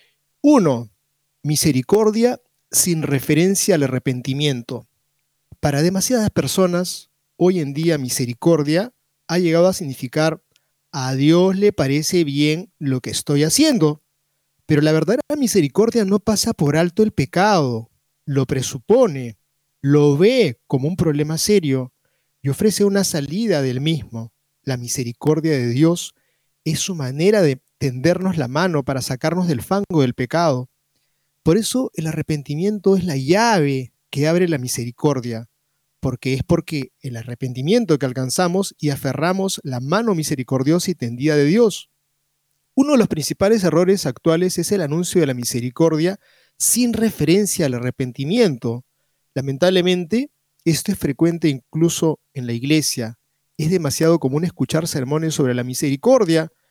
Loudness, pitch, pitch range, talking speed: -19 LUFS, 155 Hz, 135-180 Hz, 135 wpm